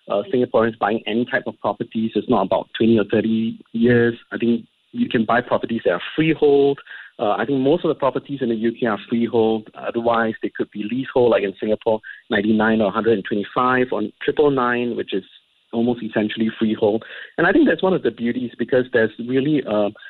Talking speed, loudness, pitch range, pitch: 220 wpm, -20 LUFS, 110-125 Hz, 115 Hz